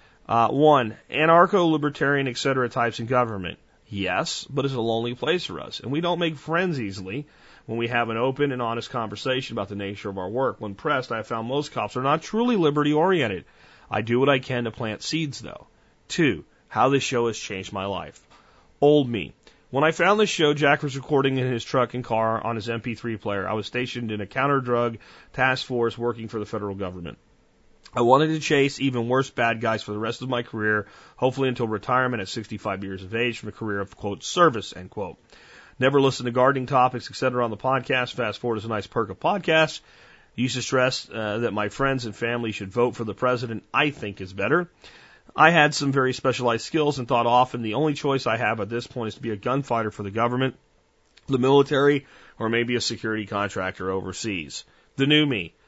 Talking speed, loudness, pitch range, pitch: 215 wpm, -24 LUFS, 110-135 Hz, 120 Hz